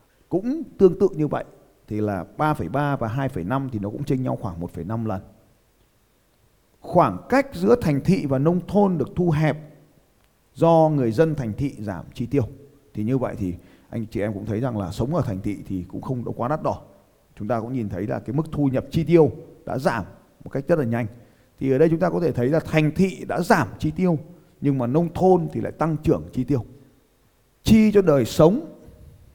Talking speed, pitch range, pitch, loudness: 220 wpm, 110-160 Hz, 135 Hz, -22 LUFS